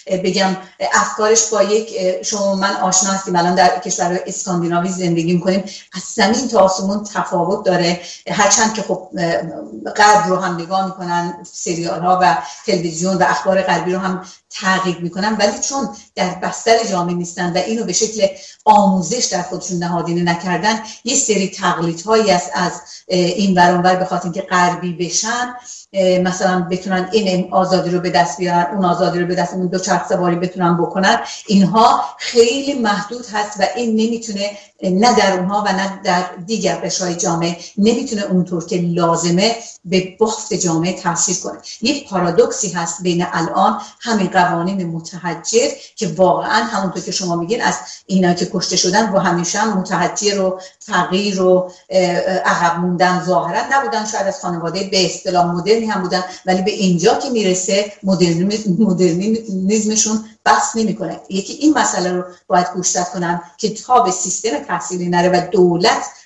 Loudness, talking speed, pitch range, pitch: -16 LUFS, 155 wpm, 175-205 Hz, 185 Hz